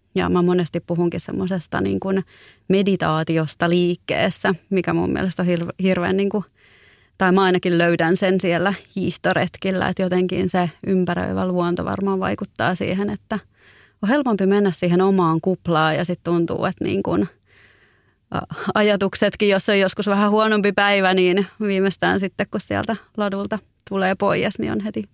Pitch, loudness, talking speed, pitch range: 185 Hz, -20 LUFS, 145 wpm, 175-200 Hz